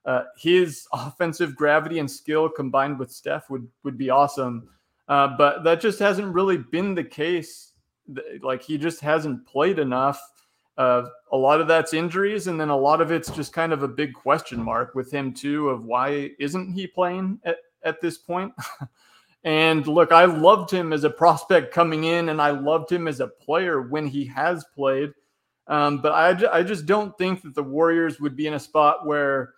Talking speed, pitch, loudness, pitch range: 195 wpm, 155 Hz, -22 LUFS, 140-170 Hz